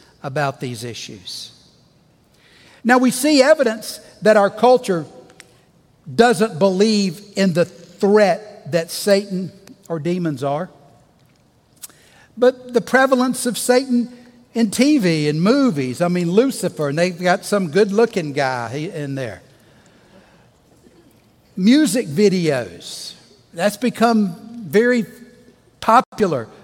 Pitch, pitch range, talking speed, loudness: 205 Hz, 170-240 Hz, 105 wpm, -18 LUFS